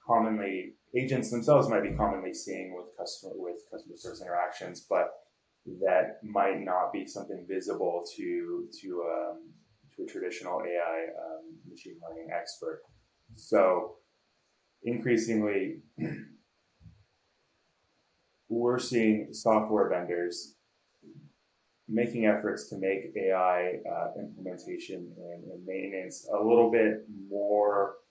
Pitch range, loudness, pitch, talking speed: 95-145 Hz, -30 LUFS, 110 Hz, 110 wpm